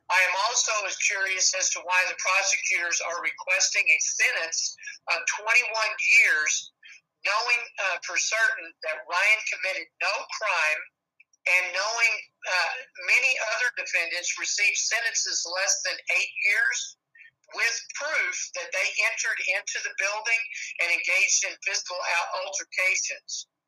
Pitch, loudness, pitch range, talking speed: 215 Hz, -24 LUFS, 185-265 Hz, 130 wpm